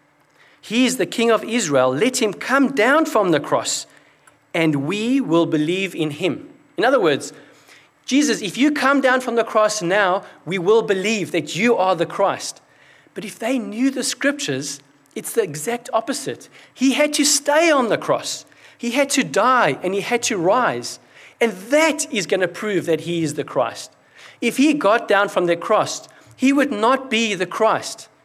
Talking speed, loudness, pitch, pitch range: 190 wpm, -19 LUFS, 225 Hz, 180-265 Hz